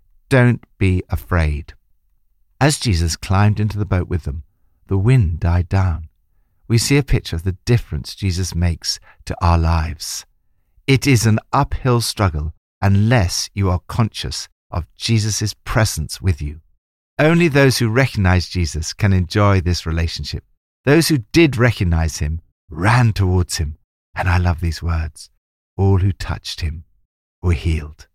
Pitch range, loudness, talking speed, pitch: 80-110 Hz, -18 LUFS, 145 wpm, 90 Hz